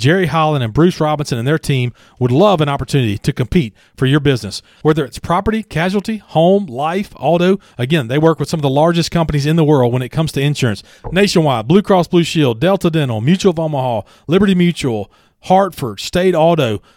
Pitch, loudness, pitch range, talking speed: 155 Hz, -15 LUFS, 130-175 Hz, 200 wpm